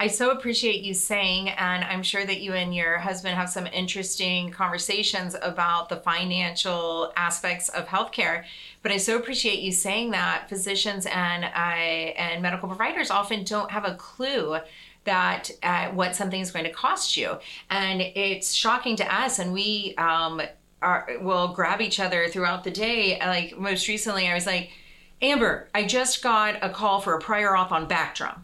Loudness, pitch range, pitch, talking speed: -25 LUFS, 180-205 Hz, 190 Hz, 175 wpm